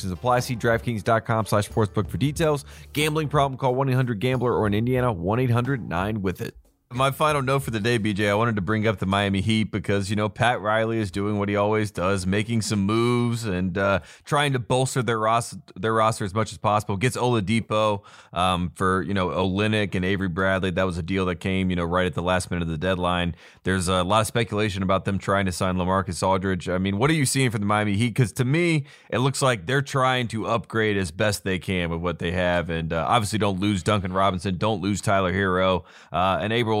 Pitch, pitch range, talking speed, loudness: 105 Hz, 95-120 Hz, 225 wpm, -23 LUFS